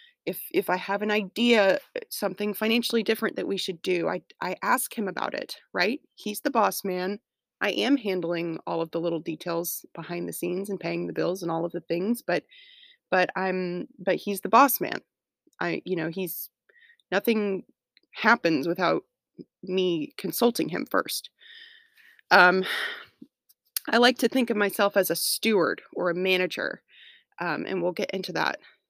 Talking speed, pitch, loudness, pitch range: 170 wpm, 195 Hz, -26 LUFS, 180-235 Hz